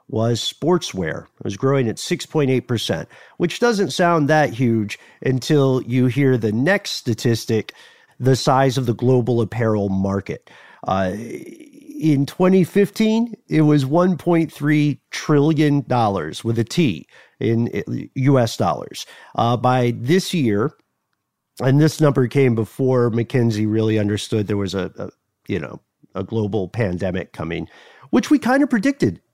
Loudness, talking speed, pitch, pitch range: -19 LUFS, 135 wpm, 130 Hz, 110-155 Hz